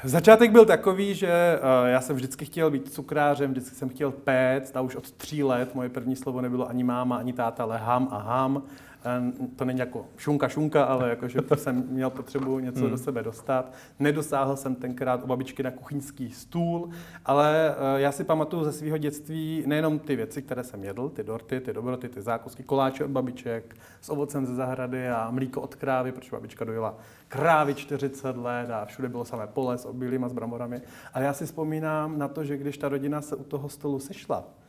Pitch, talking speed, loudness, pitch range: 130 Hz, 195 wpm, -27 LUFS, 125-145 Hz